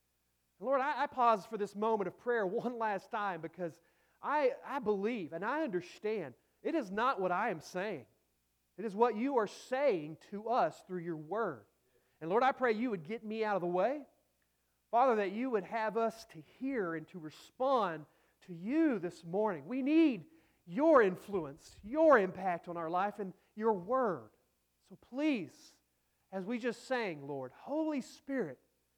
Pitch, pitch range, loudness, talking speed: 210 Hz, 170-250 Hz, -35 LUFS, 175 wpm